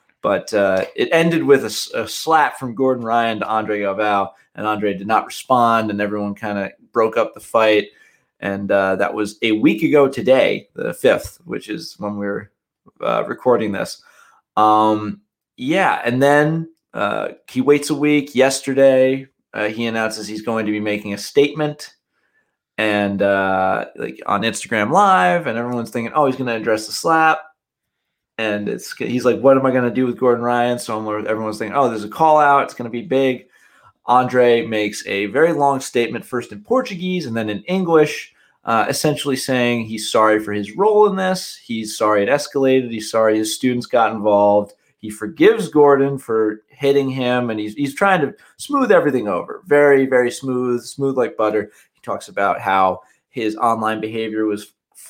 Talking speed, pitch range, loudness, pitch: 180 wpm, 105-140 Hz, -18 LUFS, 120 Hz